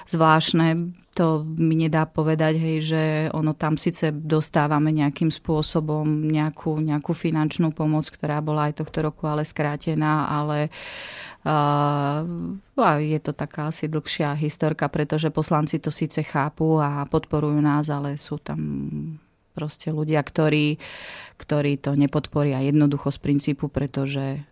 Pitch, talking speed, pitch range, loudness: 155 Hz, 135 wpm, 145-155 Hz, -23 LUFS